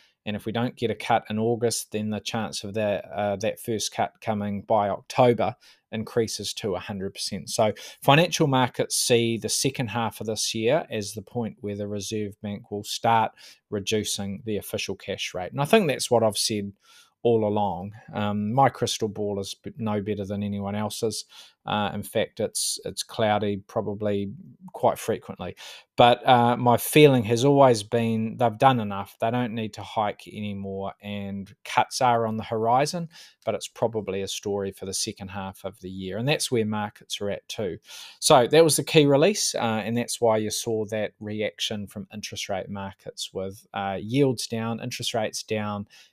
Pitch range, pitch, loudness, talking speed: 100-120 Hz, 110 Hz, -25 LUFS, 185 wpm